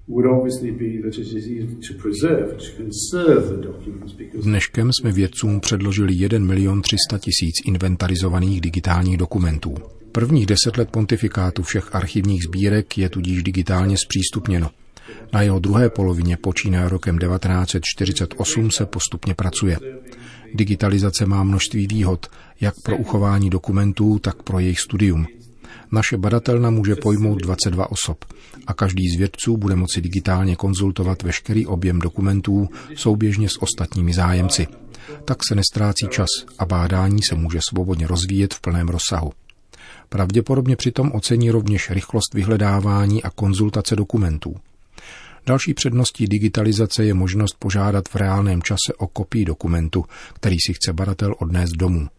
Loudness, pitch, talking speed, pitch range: -20 LUFS, 100 Hz, 120 wpm, 90-110 Hz